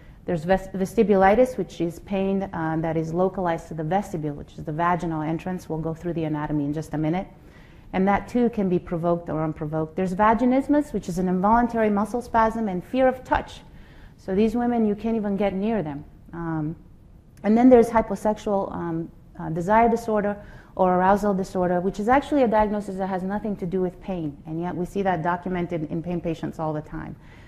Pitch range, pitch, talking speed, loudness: 165-210 Hz, 185 Hz, 200 wpm, -24 LUFS